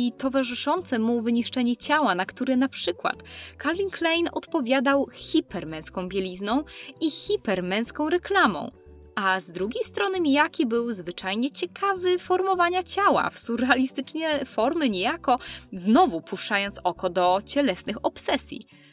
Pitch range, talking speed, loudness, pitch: 195-320 Hz, 115 wpm, -25 LUFS, 260 Hz